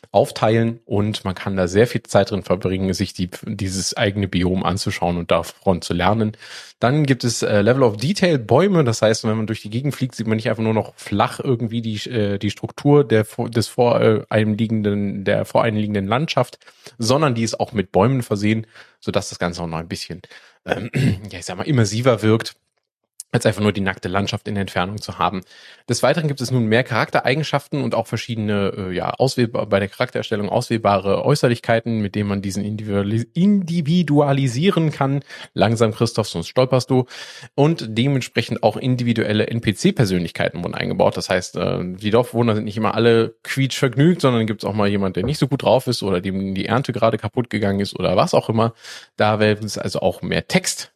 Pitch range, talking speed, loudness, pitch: 100-125 Hz, 185 wpm, -20 LUFS, 110 Hz